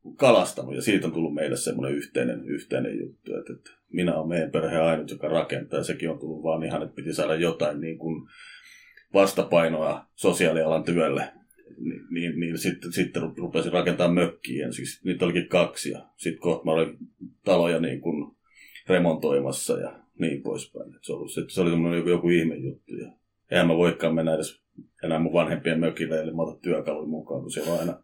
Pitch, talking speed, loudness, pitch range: 80 Hz, 180 wpm, -26 LUFS, 80-85 Hz